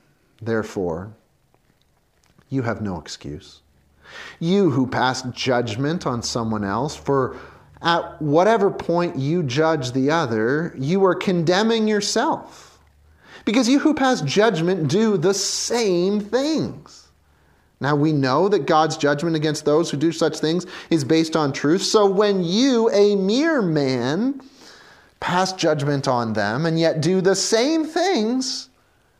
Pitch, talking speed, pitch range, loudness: 160 Hz, 135 wpm, 125-195 Hz, -20 LUFS